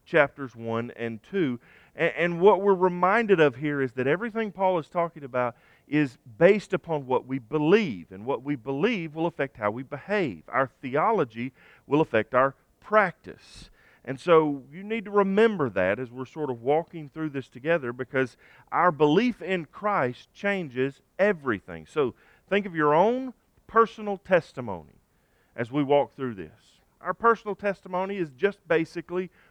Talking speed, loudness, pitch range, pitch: 160 wpm, -26 LUFS, 130-190 Hz, 155 Hz